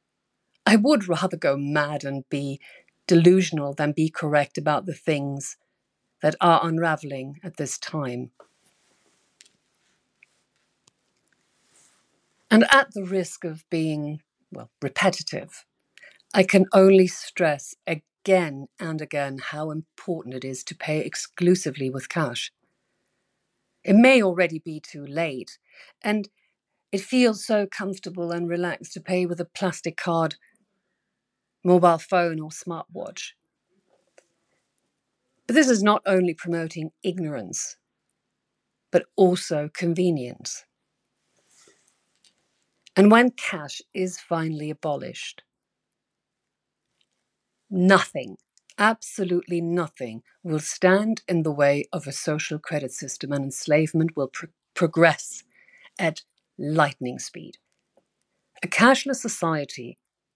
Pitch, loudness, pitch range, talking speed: 170 Hz, -23 LUFS, 150-190 Hz, 105 wpm